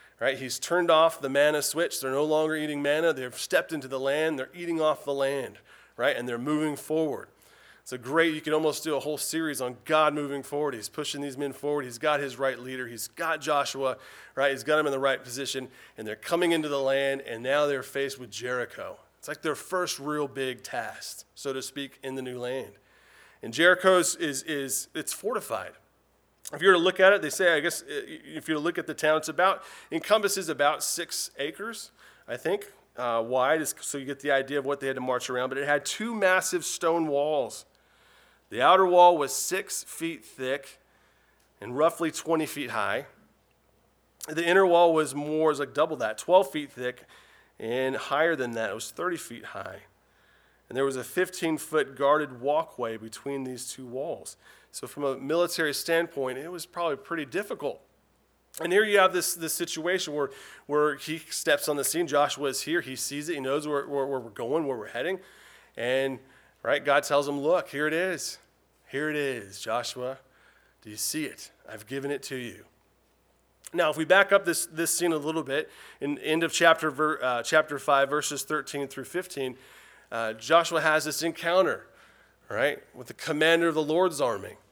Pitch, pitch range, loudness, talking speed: 150 Hz, 135-165 Hz, -27 LUFS, 205 wpm